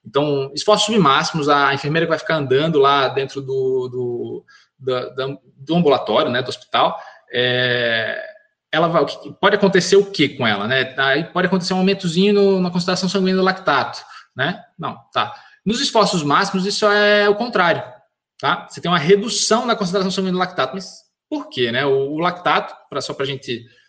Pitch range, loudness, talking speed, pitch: 140-205 Hz, -18 LUFS, 180 wpm, 180 Hz